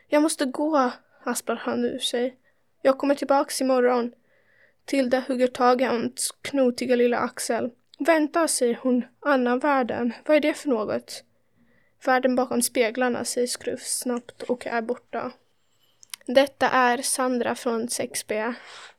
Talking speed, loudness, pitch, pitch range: 135 wpm, -24 LUFS, 255 Hz, 245-275 Hz